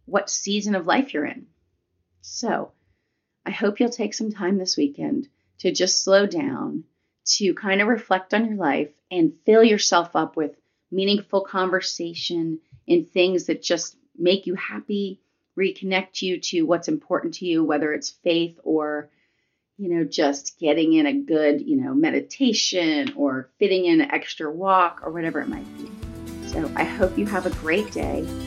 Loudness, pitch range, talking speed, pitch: -22 LUFS, 155-215 Hz, 170 wpm, 185 Hz